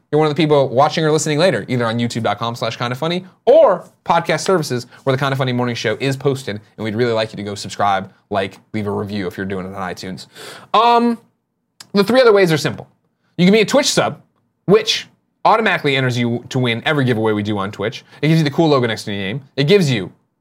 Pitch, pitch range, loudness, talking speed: 130 Hz, 110-160 Hz, -17 LUFS, 245 wpm